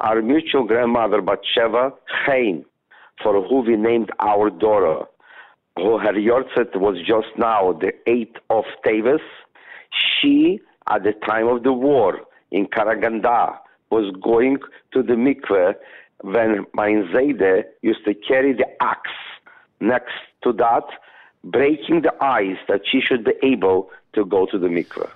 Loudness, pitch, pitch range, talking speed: -19 LUFS, 115 Hz, 105-135 Hz, 135 wpm